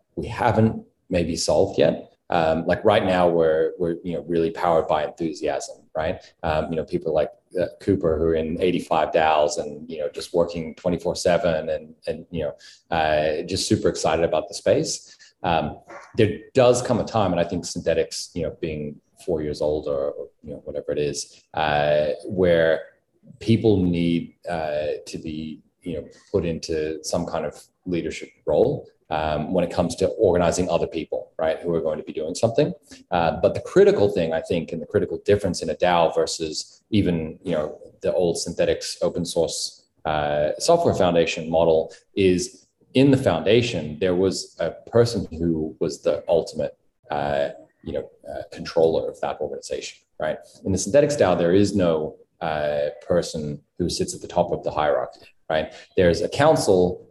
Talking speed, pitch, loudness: 180 wpm, 95 Hz, -23 LUFS